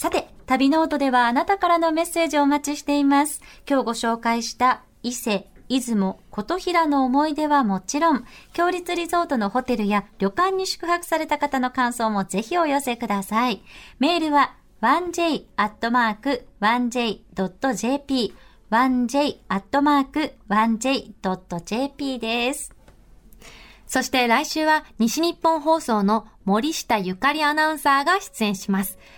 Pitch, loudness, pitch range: 265 Hz, -22 LUFS, 225-305 Hz